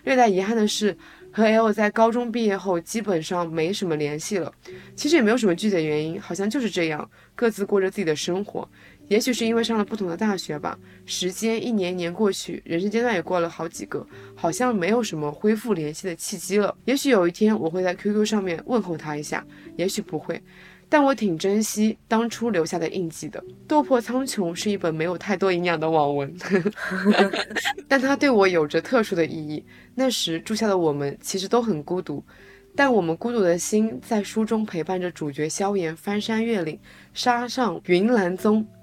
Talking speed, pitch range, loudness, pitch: 300 characters per minute, 170-220 Hz, -23 LUFS, 195 Hz